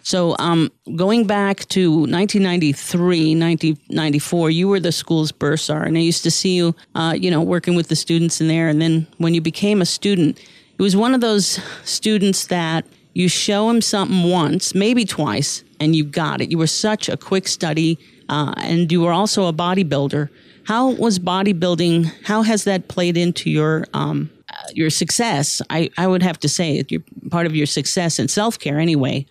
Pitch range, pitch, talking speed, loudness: 160-190 Hz, 170 Hz, 185 wpm, -18 LUFS